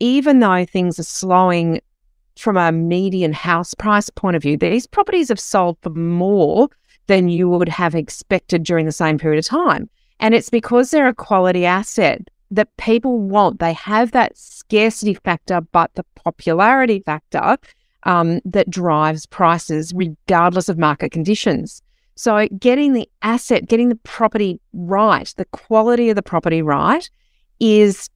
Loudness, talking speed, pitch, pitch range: -16 LUFS, 155 wpm, 195 Hz, 170-230 Hz